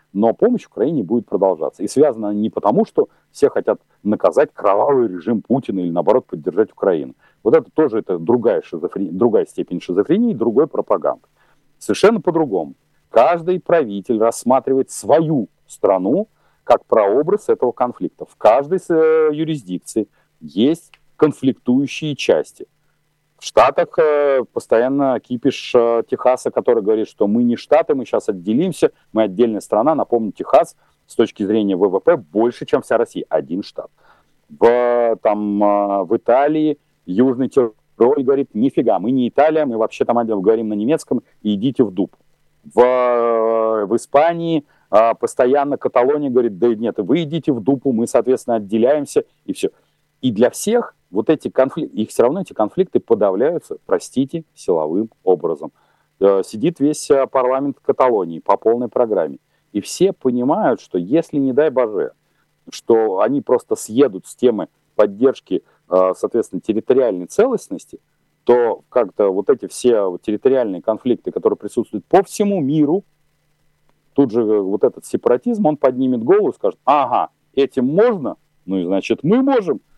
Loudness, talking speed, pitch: -17 LUFS, 145 wpm, 140 Hz